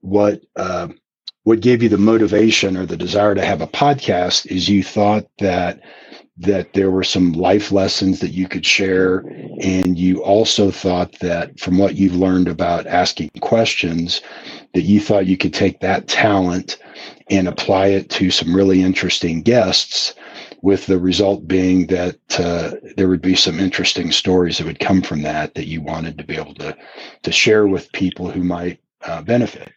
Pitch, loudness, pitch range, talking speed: 95 Hz, -16 LUFS, 90-100 Hz, 175 wpm